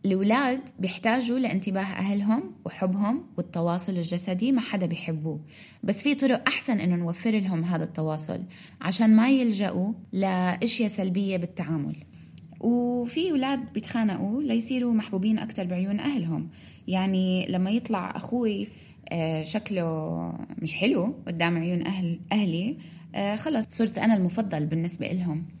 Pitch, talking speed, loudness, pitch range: 195 Hz, 115 wpm, -27 LUFS, 175-225 Hz